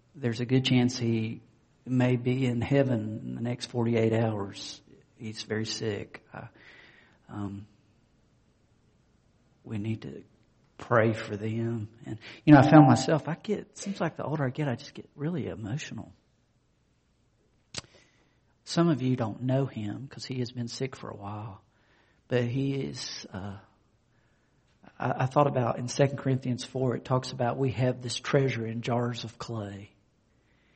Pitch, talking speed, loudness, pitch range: 120 Hz, 160 wpm, -28 LUFS, 110-130 Hz